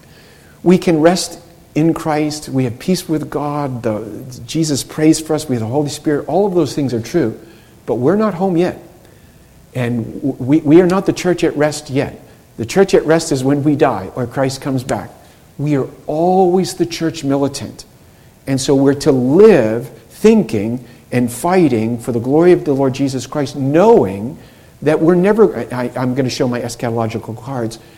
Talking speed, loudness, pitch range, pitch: 190 wpm, -15 LUFS, 125-165 Hz, 140 Hz